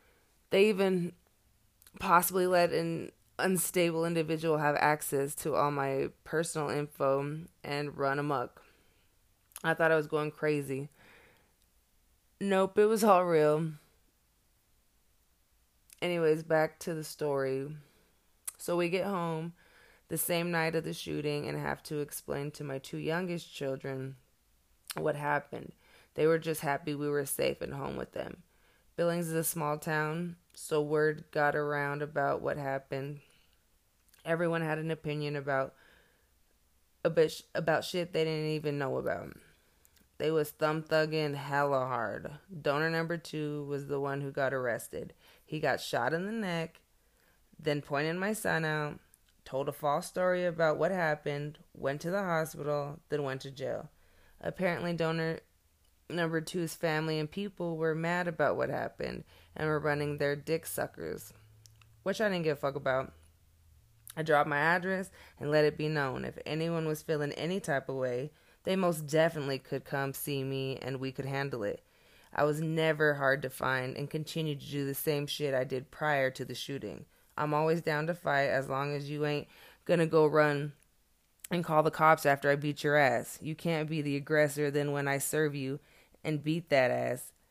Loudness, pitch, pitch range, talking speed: -32 LUFS, 150 Hz, 140-165 Hz, 165 wpm